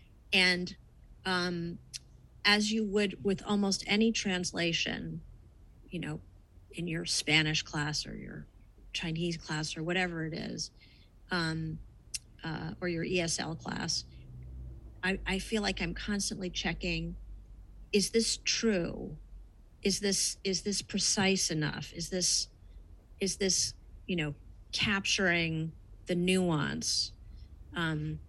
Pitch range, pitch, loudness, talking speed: 150-190 Hz, 170 Hz, -31 LUFS, 115 wpm